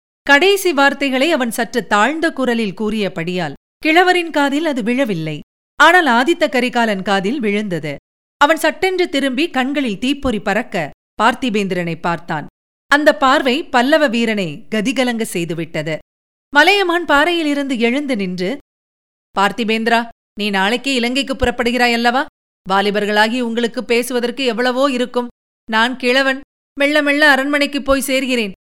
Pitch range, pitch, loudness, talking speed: 210-280 Hz, 245 Hz, -15 LUFS, 110 wpm